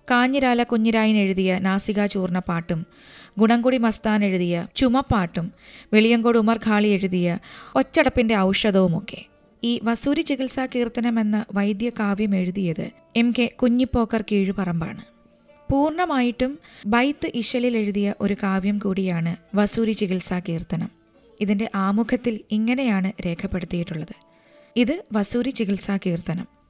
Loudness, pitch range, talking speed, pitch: -22 LUFS, 190-240 Hz, 105 wpm, 215 Hz